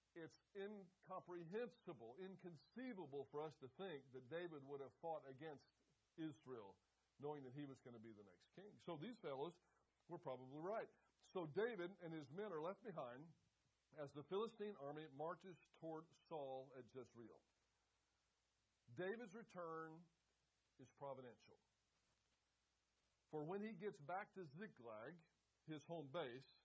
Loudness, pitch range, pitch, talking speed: -55 LUFS, 135-180 Hz, 155 Hz, 135 wpm